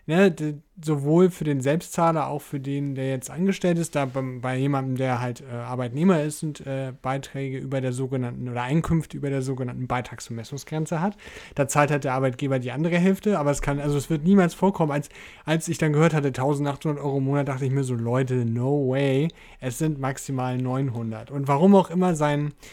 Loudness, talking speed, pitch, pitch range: -24 LUFS, 200 wpm, 140 Hz, 130-155 Hz